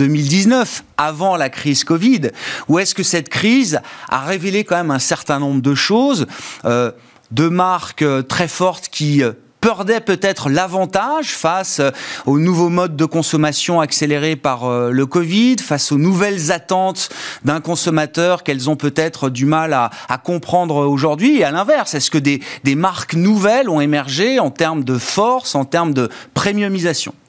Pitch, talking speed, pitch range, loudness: 165 Hz, 160 wpm, 145-190 Hz, -16 LUFS